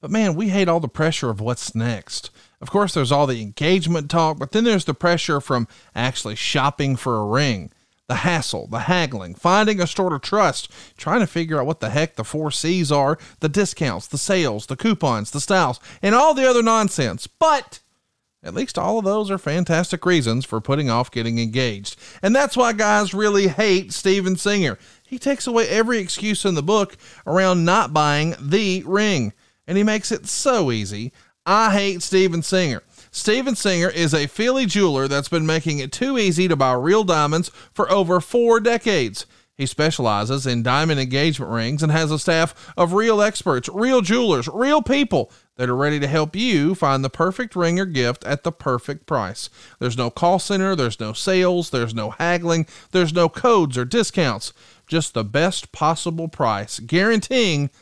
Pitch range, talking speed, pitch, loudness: 135-195 Hz, 185 wpm, 165 Hz, -20 LUFS